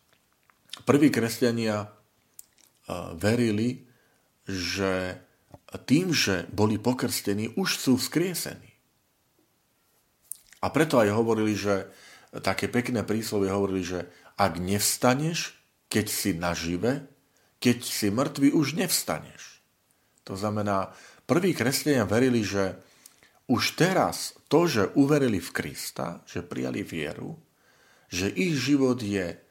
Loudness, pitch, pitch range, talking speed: -26 LUFS, 105 Hz, 95-125 Hz, 105 wpm